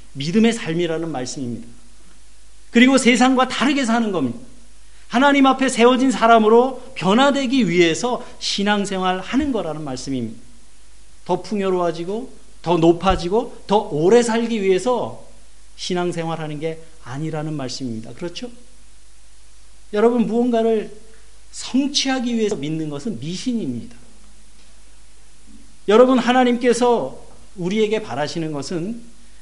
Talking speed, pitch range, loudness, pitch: 285 characters per minute, 160-240 Hz, -19 LUFS, 210 Hz